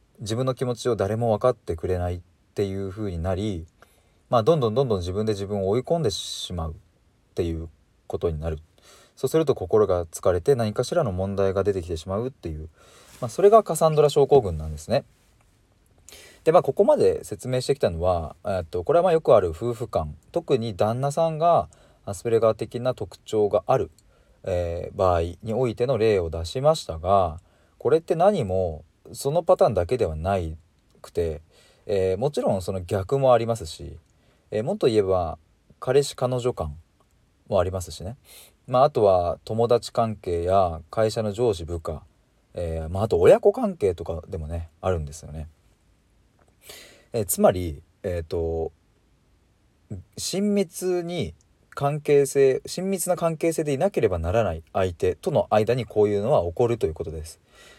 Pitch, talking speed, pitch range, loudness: 100 Hz, 330 characters per minute, 85-125 Hz, -24 LUFS